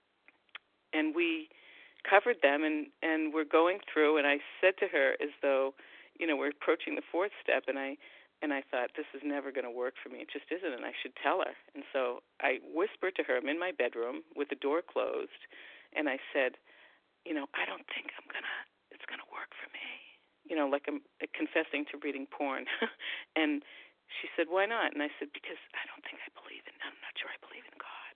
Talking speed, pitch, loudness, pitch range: 215 wpm, 150 Hz, -34 LUFS, 140-195 Hz